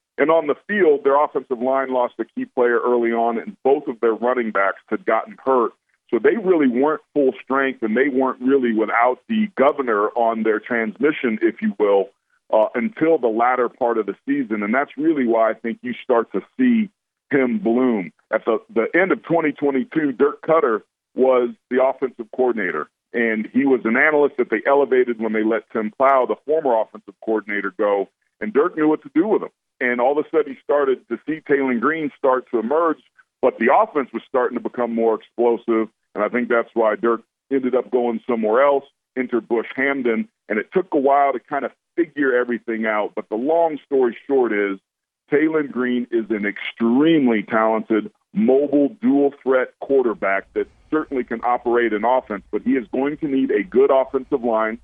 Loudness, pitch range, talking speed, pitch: -20 LUFS, 115-145 Hz, 195 wpm, 125 Hz